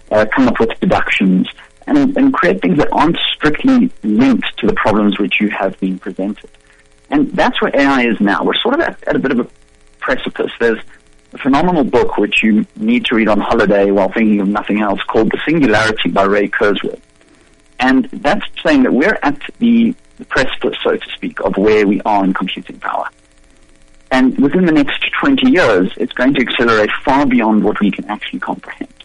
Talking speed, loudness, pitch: 195 wpm, -14 LUFS, 105 Hz